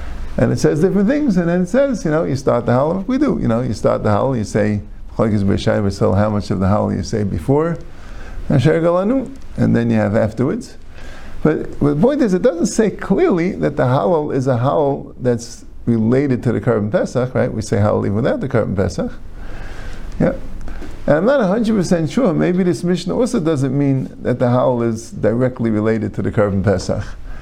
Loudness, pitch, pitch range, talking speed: -17 LUFS, 120 Hz, 105-170 Hz, 195 wpm